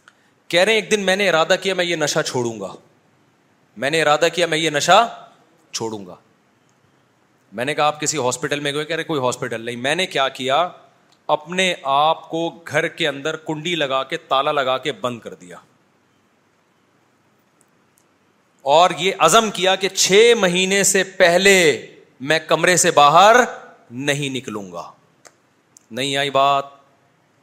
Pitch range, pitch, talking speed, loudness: 140-180 Hz, 155 Hz, 160 wpm, -17 LUFS